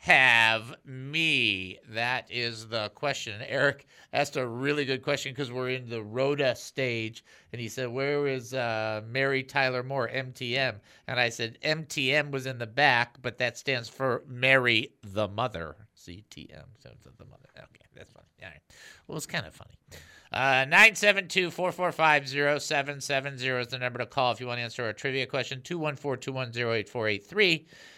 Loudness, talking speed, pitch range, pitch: -27 LUFS, 160 wpm, 120-140 Hz, 130 Hz